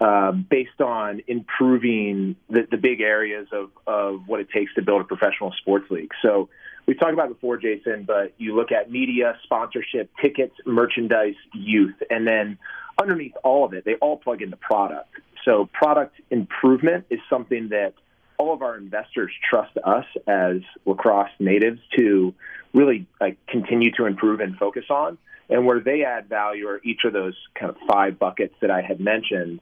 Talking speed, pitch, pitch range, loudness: 175 wpm, 115 Hz, 100-125 Hz, -22 LUFS